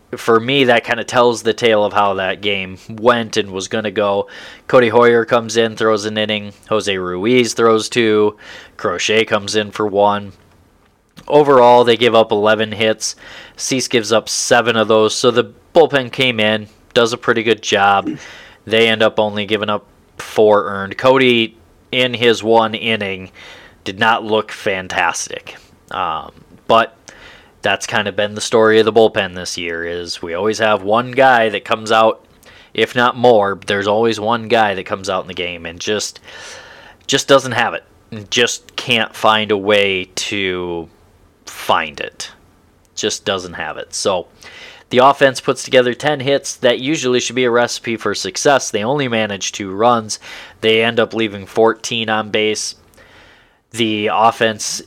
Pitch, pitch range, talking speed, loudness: 110 Hz, 105-120 Hz, 170 wpm, -15 LUFS